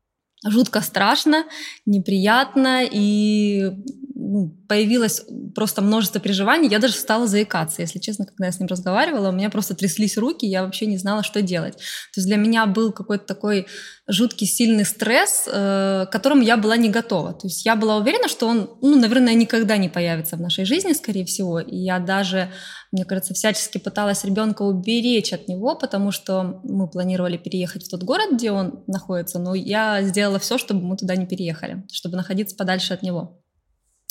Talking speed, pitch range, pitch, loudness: 175 wpm, 185-225 Hz, 205 Hz, -20 LUFS